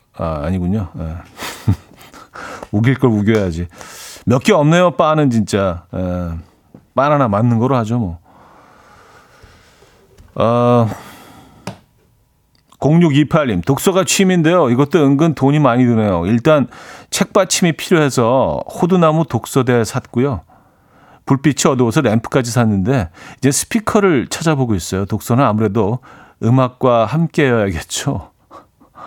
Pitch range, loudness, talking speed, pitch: 105-155 Hz, -15 LUFS, 240 characters per minute, 125 Hz